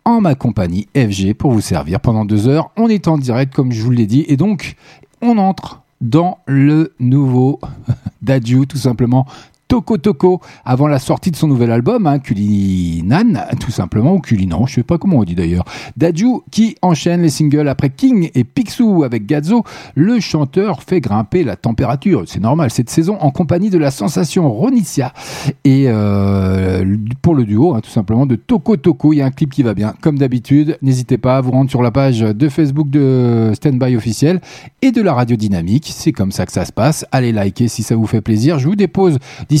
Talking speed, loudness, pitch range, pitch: 205 wpm, -14 LUFS, 115-165 Hz, 135 Hz